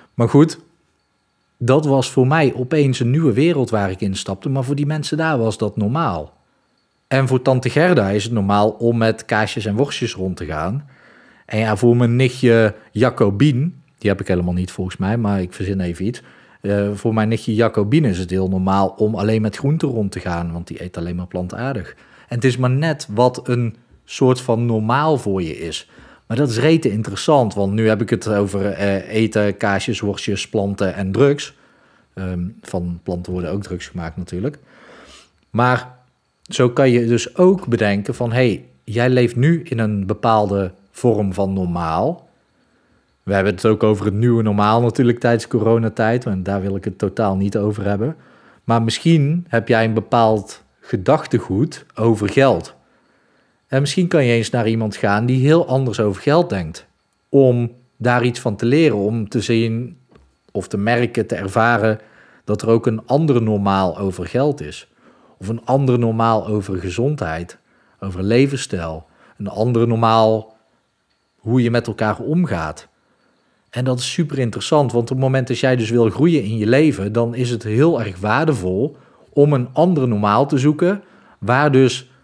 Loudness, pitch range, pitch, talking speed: -18 LUFS, 100-130 Hz, 115 Hz, 180 wpm